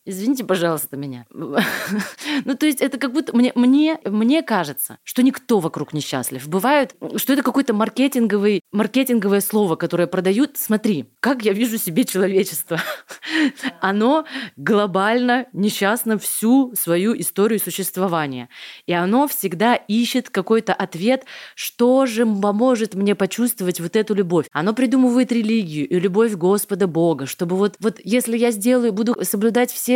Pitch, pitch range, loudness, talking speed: 215 Hz, 185-250 Hz, -19 LUFS, 135 wpm